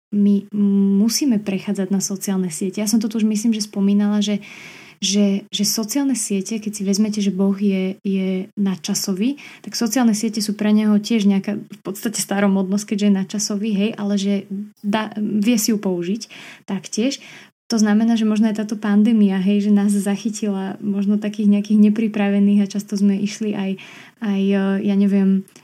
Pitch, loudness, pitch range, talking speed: 205 Hz, -19 LUFS, 195-215 Hz, 170 wpm